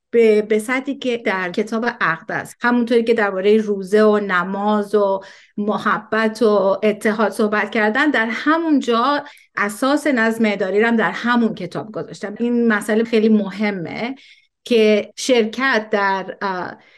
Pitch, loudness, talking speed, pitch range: 220 Hz, -18 LUFS, 130 wpm, 205-235 Hz